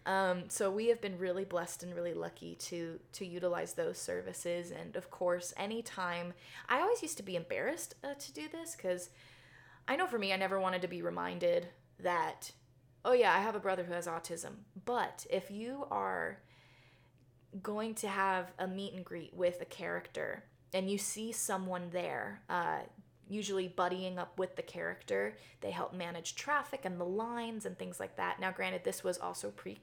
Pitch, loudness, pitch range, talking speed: 185 Hz, -38 LUFS, 175-215 Hz, 185 wpm